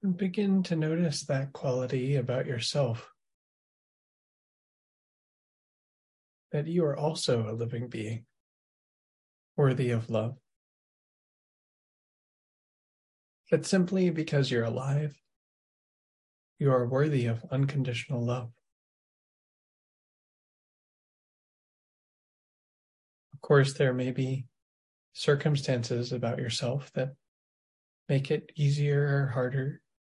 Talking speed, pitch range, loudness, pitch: 85 wpm, 120-145 Hz, -29 LUFS, 130 Hz